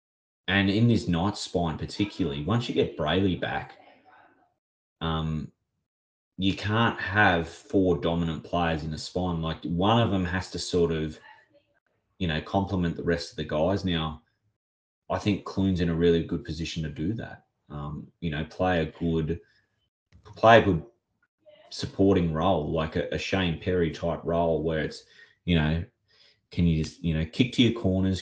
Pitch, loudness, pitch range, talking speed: 85 Hz, -27 LUFS, 80-95 Hz, 170 wpm